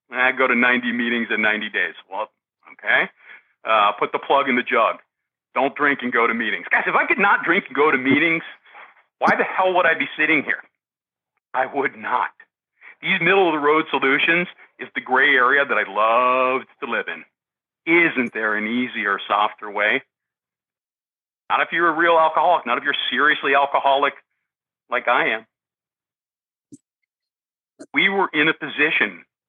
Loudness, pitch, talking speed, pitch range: -19 LUFS, 140 Hz, 175 wpm, 125-160 Hz